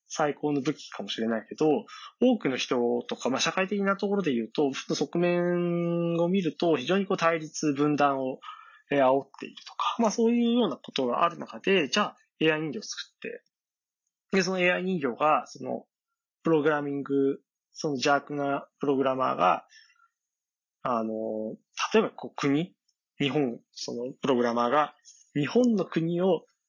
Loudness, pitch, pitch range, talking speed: -27 LUFS, 165 Hz, 140-200 Hz, 310 characters per minute